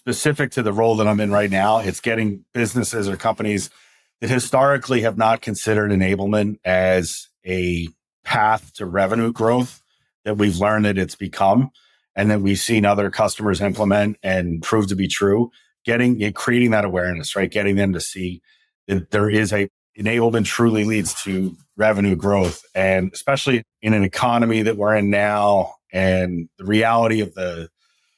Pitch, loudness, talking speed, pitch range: 105 Hz, -19 LUFS, 165 wpm, 95-115 Hz